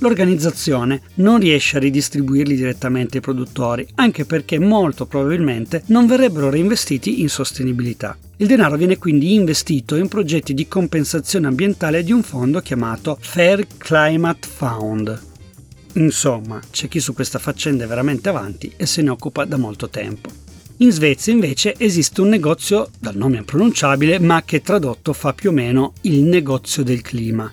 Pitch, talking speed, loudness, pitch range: 145 Hz, 155 wpm, -17 LUFS, 130-175 Hz